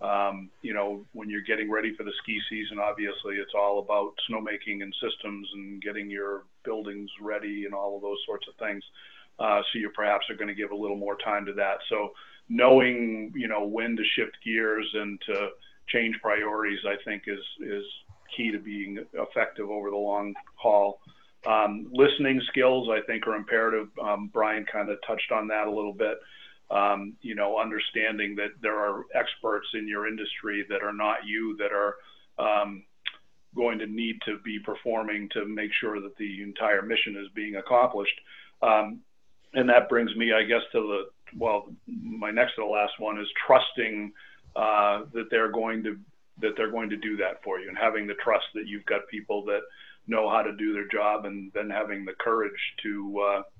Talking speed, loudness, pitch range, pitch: 195 wpm, -28 LUFS, 100-110 Hz, 105 Hz